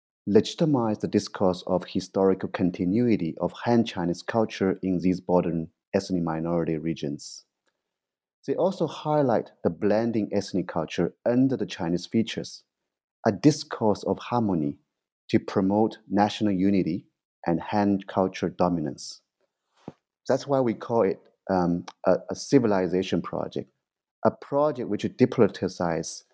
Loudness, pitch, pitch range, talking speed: -26 LUFS, 100 Hz, 90-115 Hz, 120 wpm